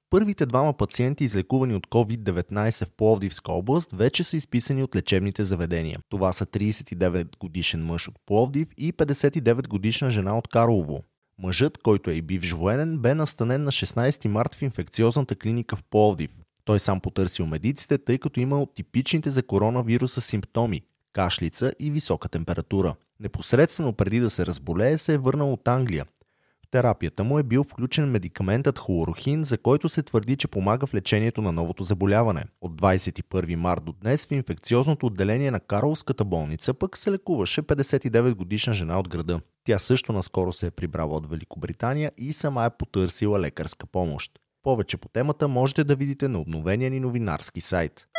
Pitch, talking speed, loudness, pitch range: 110 Hz, 160 wpm, -25 LUFS, 95-135 Hz